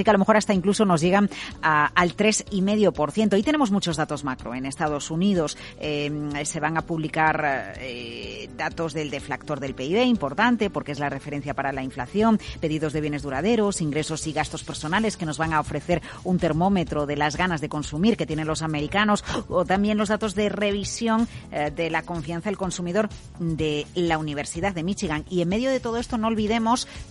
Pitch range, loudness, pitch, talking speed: 150-205 Hz, -24 LUFS, 165 Hz, 200 wpm